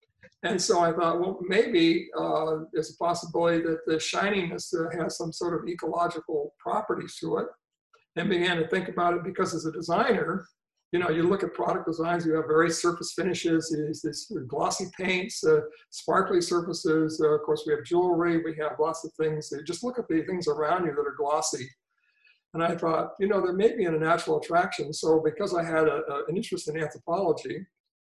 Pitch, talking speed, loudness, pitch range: 170 Hz, 205 wpm, -27 LUFS, 160-195 Hz